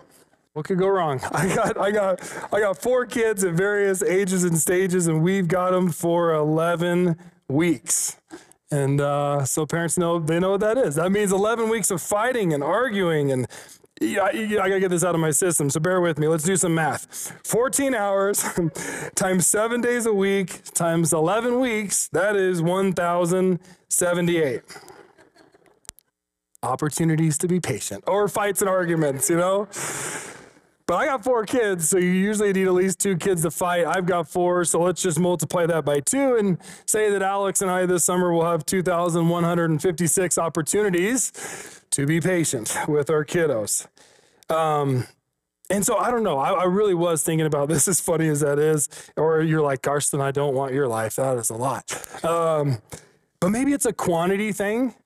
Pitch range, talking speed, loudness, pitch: 160-195 Hz, 180 wpm, -22 LUFS, 180 Hz